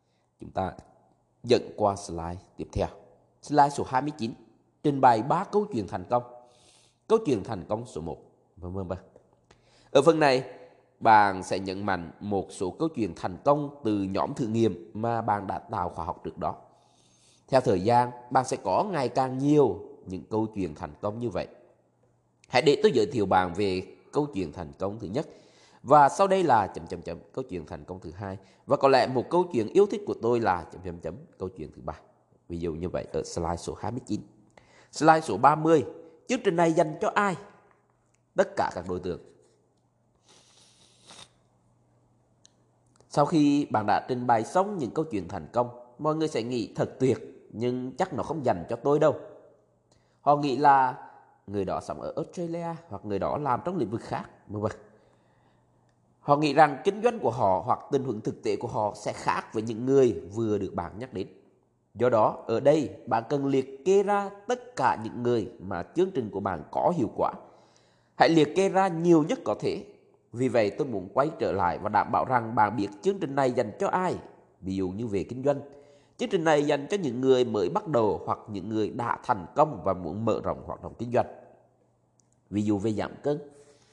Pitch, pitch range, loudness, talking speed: 120 Hz, 100-150 Hz, -27 LUFS, 200 wpm